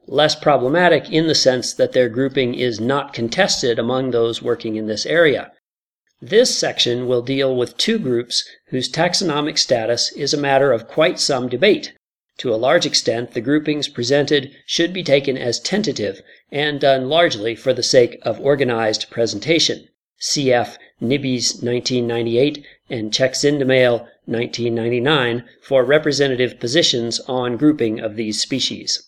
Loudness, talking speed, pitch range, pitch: -18 LUFS, 140 wpm, 120-145 Hz, 130 Hz